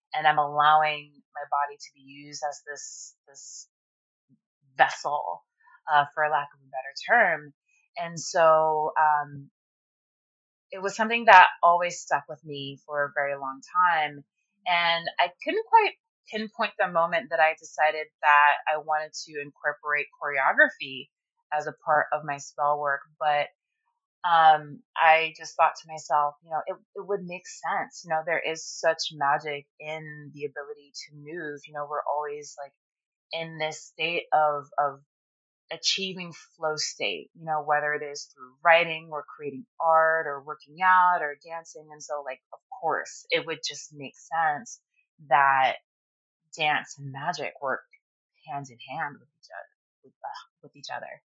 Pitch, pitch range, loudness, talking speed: 155 Hz, 145-170 Hz, -25 LUFS, 160 wpm